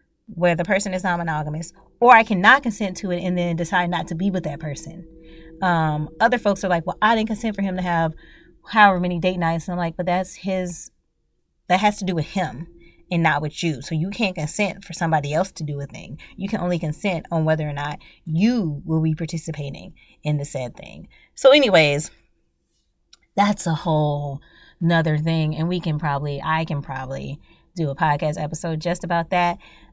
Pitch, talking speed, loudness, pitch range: 165 Hz, 205 wpm, -21 LUFS, 155-185 Hz